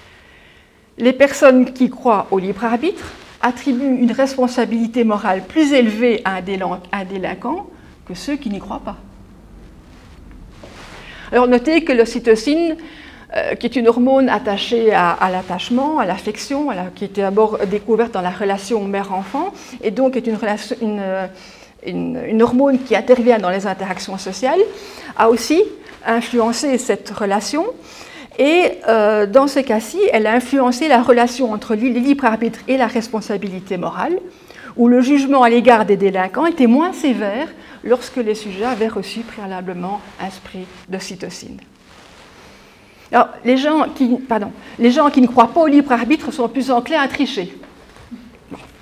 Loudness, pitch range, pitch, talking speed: -16 LUFS, 205-265 Hz, 235 Hz, 150 wpm